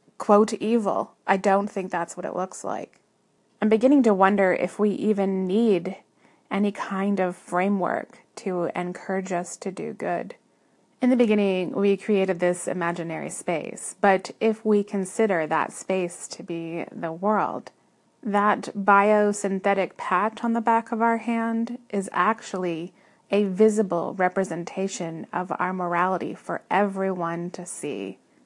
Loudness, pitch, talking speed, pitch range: -24 LUFS, 195 Hz, 140 wpm, 180-215 Hz